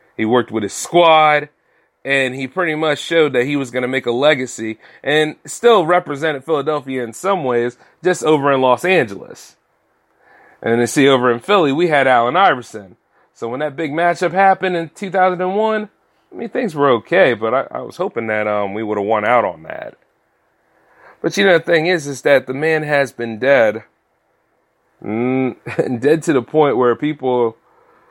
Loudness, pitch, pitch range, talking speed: -16 LUFS, 140 Hz, 125-165 Hz, 190 wpm